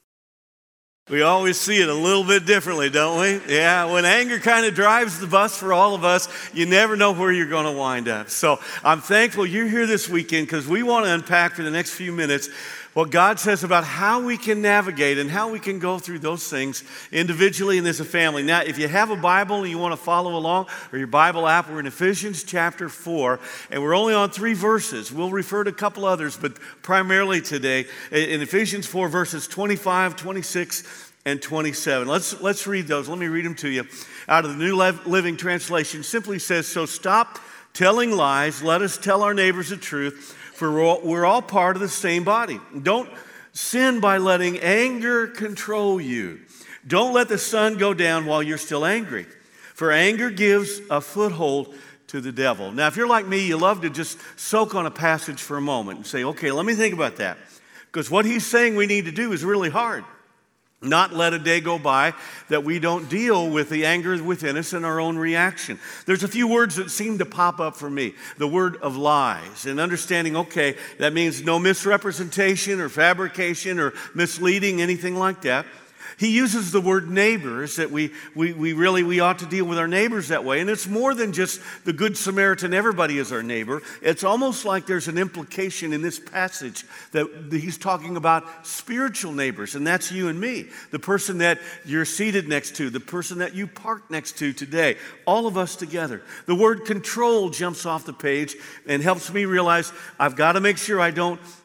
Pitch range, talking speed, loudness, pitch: 160-200 Hz, 205 wpm, -21 LUFS, 180 Hz